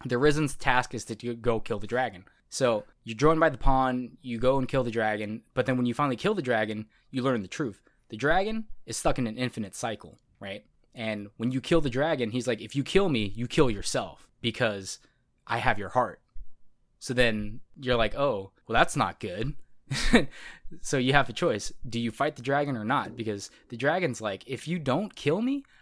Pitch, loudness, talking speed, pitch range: 125 Hz, -28 LUFS, 215 wpm, 115-140 Hz